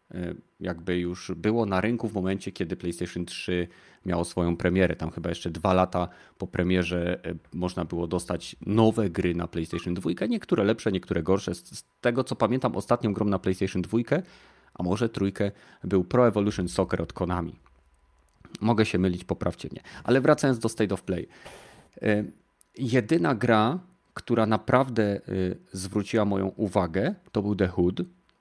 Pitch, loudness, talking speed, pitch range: 95 Hz, -27 LUFS, 150 wpm, 90-110 Hz